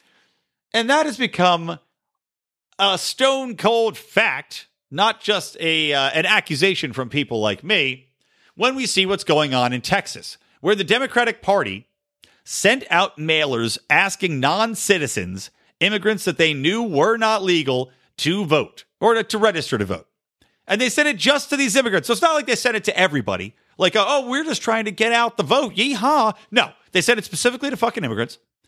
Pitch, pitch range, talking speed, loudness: 200 Hz, 155-235 Hz, 180 wpm, -19 LUFS